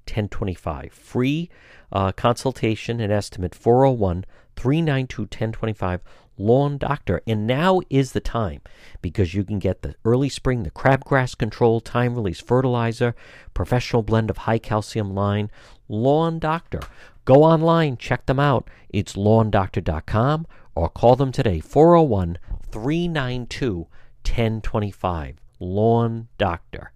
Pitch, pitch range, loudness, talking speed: 115 Hz, 100-130 Hz, -21 LUFS, 110 wpm